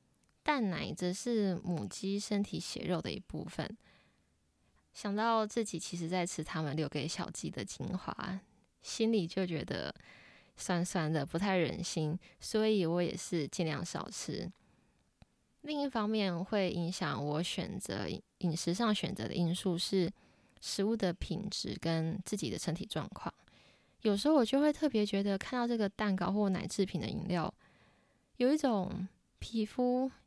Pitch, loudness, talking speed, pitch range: 190 Hz, -35 LUFS, 220 characters per minute, 170-210 Hz